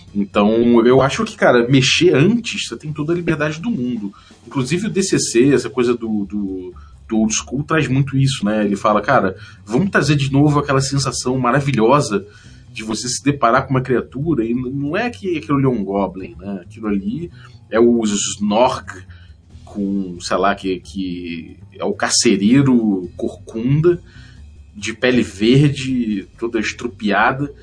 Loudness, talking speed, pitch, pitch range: -17 LUFS, 160 wpm, 115 Hz, 100-135 Hz